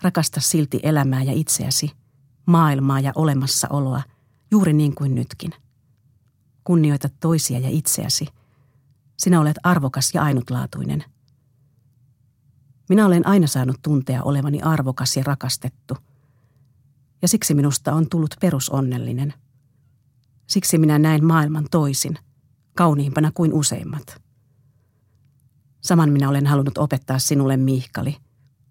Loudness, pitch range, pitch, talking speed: -19 LUFS, 130-155 Hz, 135 Hz, 105 wpm